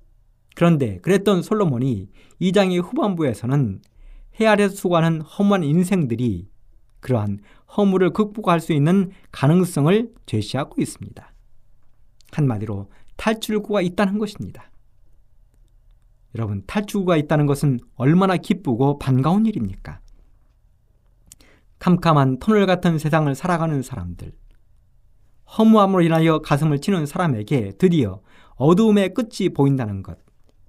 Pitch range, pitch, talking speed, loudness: 115-190 Hz, 150 Hz, 285 characters per minute, -20 LUFS